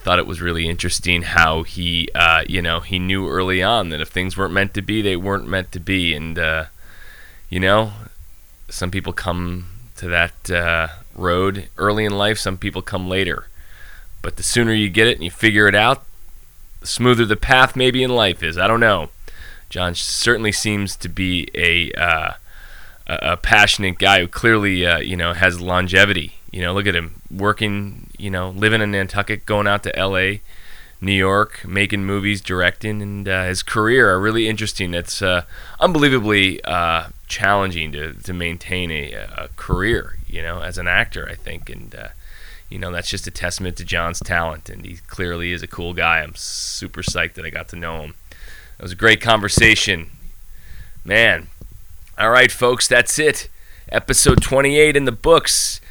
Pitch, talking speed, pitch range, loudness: 95 Hz, 185 wpm, 85-105 Hz, -17 LUFS